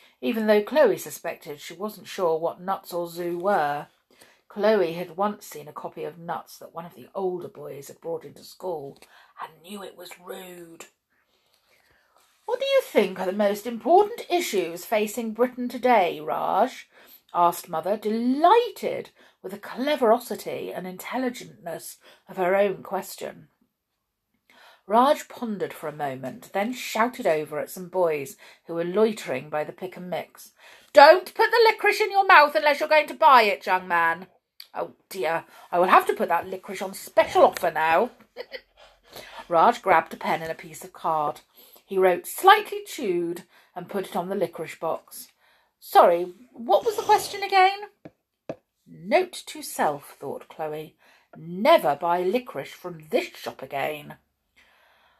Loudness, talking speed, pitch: -23 LUFS, 160 wpm, 205 Hz